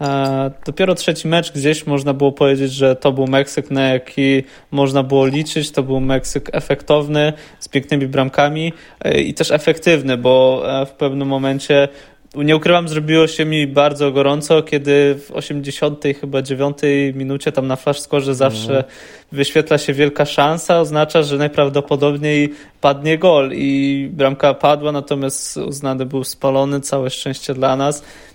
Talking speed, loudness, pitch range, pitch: 145 wpm, -16 LUFS, 135-150 Hz, 140 Hz